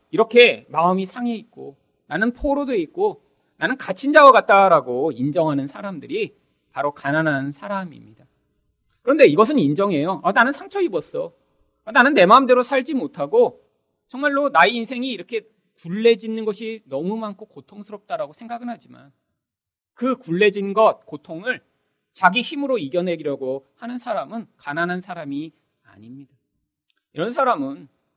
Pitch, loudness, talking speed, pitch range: 215 Hz, -19 LUFS, 315 characters per minute, 165-255 Hz